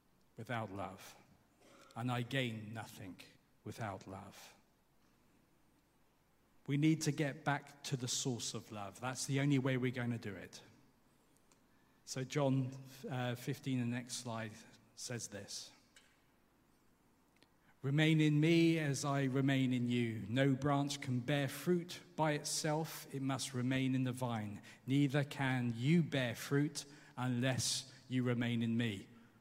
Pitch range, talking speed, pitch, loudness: 115-140 Hz, 135 wpm, 130 Hz, -37 LUFS